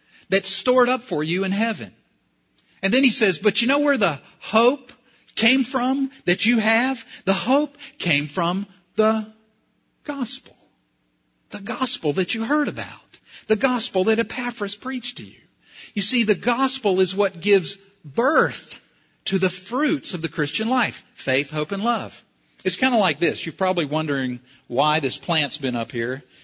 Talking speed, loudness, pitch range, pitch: 170 wpm, -22 LUFS, 170-250 Hz, 205 Hz